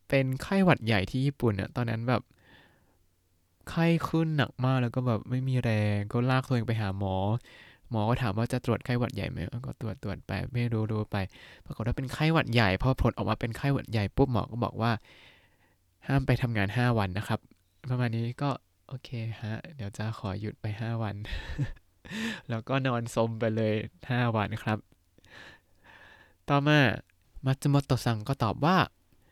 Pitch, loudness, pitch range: 115 Hz, -29 LUFS, 105-130 Hz